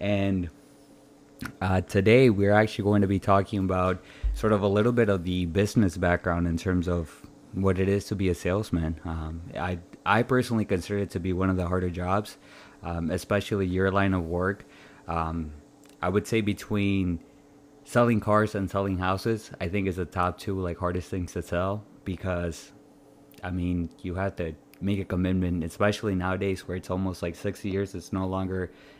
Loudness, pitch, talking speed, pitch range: -27 LUFS, 95 Hz, 185 wpm, 90-100 Hz